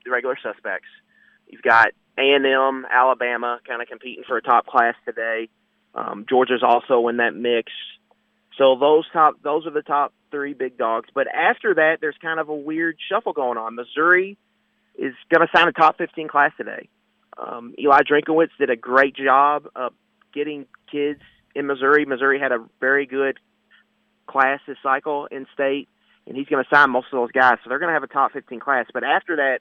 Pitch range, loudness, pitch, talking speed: 125-150 Hz, -20 LUFS, 140 Hz, 190 wpm